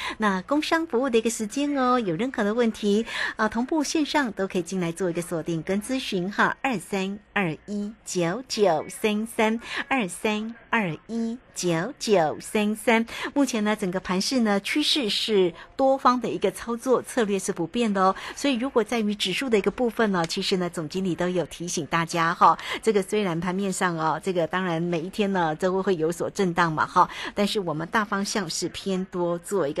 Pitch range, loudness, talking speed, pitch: 180-235 Hz, -25 LUFS, 290 characters per minute, 205 Hz